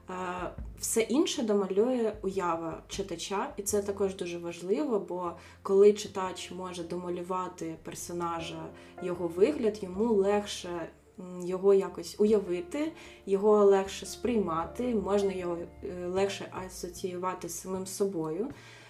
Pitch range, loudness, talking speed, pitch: 175-205 Hz, -31 LUFS, 105 wpm, 190 Hz